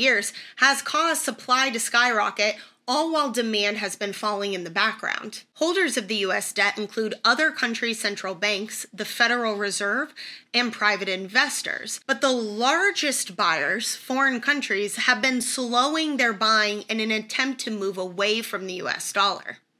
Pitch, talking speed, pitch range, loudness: 225 Hz, 160 wpm, 205-260 Hz, -23 LUFS